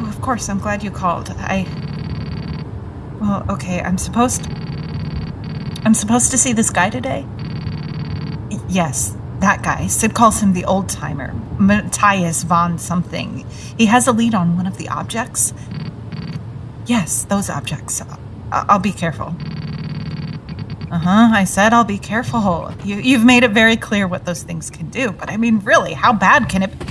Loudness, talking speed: -17 LUFS, 155 wpm